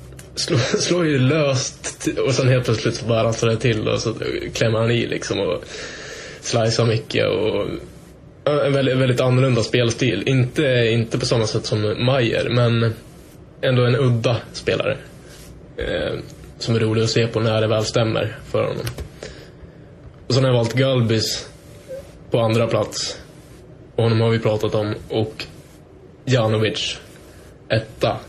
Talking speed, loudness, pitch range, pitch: 150 wpm, -20 LUFS, 115-135 Hz, 120 Hz